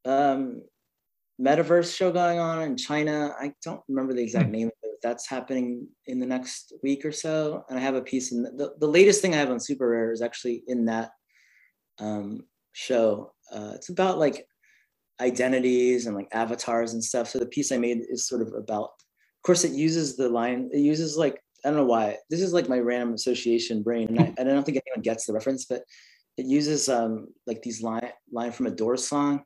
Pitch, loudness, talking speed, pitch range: 130 Hz, -26 LUFS, 215 wpm, 120-145 Hz